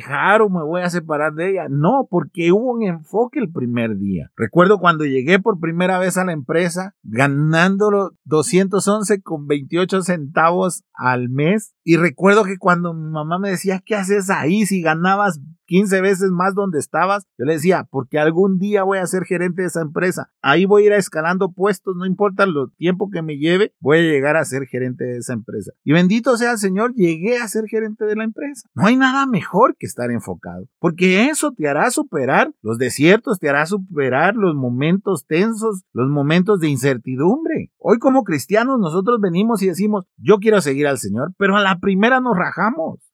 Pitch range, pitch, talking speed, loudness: 155-205 Hz, 185 Hz, 195 wpm, -17 LUFS